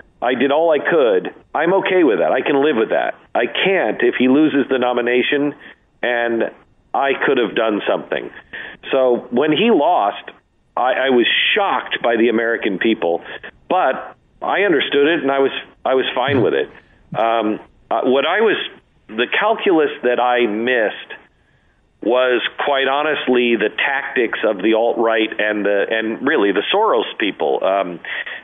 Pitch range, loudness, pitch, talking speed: 115-135 Hz, -17 LUFS, 125 Hz, 160 wpm